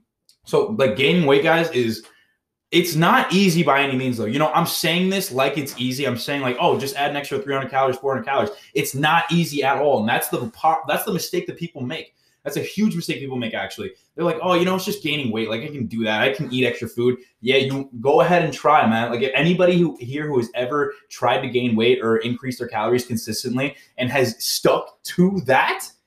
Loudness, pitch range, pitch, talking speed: -20 LUFS, 125-170 Hz, 140 Hz, 235 wpm